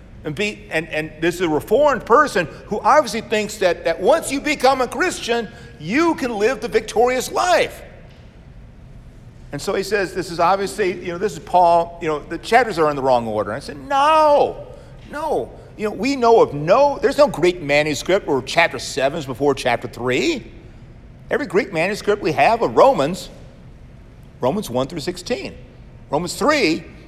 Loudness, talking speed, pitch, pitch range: -18 LUFS, 180 wpm, 185 Hz, 155-240 Hz